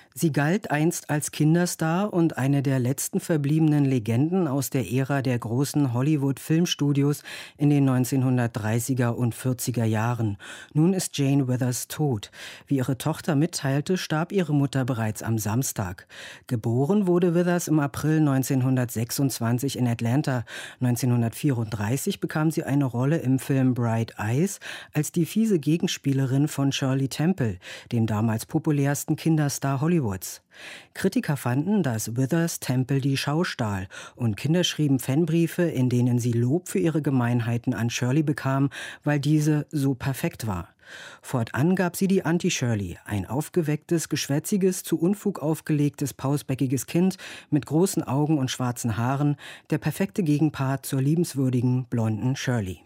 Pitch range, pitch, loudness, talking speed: 125-160 Hz, 140 Hz, -25 LUFS, 135 wpm